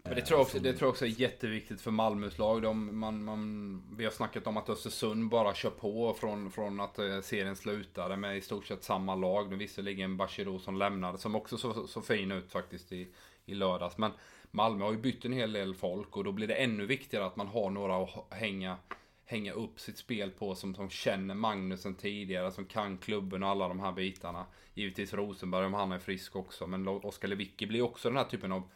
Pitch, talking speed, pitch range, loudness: 100 Hz, 220 wpm, 95-110 Hz, -35 LUFS